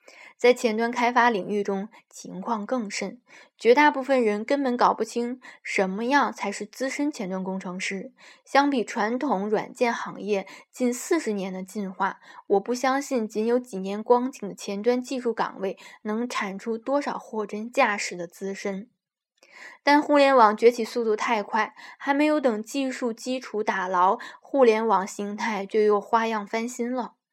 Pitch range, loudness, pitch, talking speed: 205-255 Hz, -25 LUFS, 225 Hz, 240 characters per minute